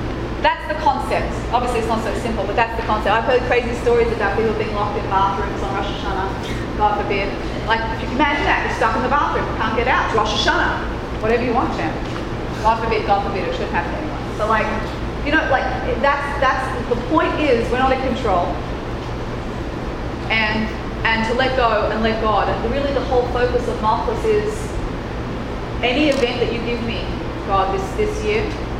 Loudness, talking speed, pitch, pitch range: -19 LUFS, 195 wpm, 255 Hz, 230-280 Hz